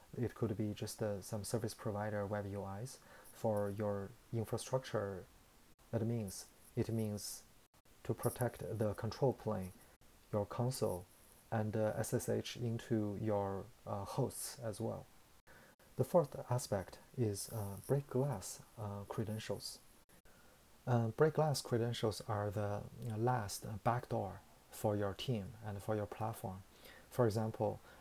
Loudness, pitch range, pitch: -40 LUFS, 105-120 Hz, 110 Hz